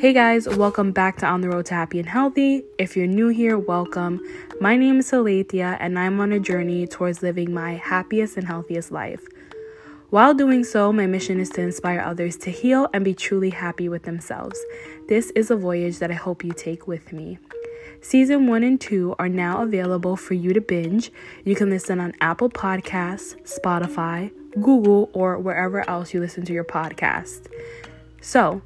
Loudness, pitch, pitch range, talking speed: -21 LUFS, 185 Hz, 175-220 Hz, 185 wpm